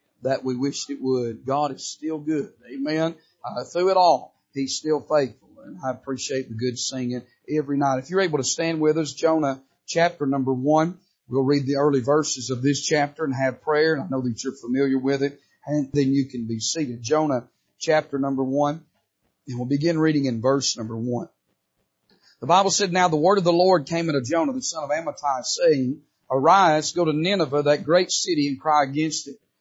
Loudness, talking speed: -23 LUFS, 205 wpm